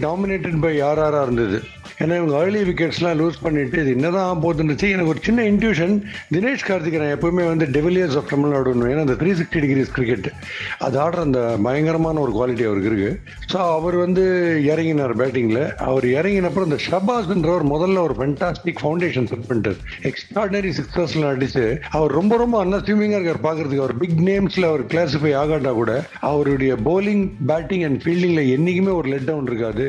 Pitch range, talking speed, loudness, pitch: 140-180 Hz, 165 wpm, -19 LUFS, 160 Hz